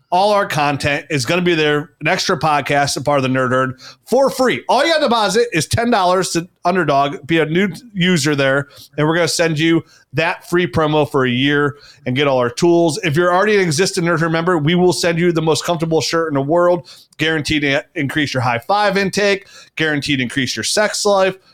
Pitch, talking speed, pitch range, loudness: 165 Hz, 225 wpm, 145-180 Hz, -16 LUFS